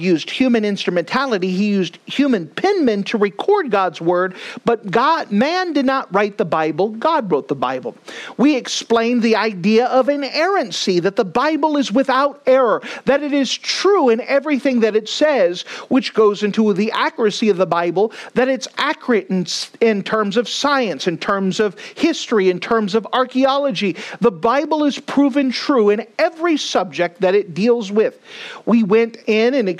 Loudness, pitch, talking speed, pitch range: -17 LUFS, 230 Hz, 165 wpm, 205-275 Hz